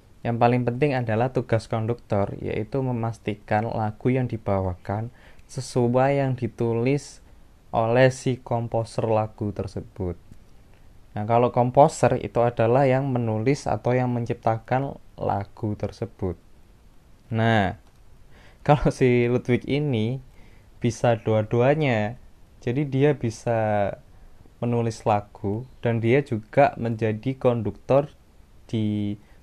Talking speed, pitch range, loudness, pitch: 100 wpm, 105-125 Hz, -24 LUFS, 115 Hz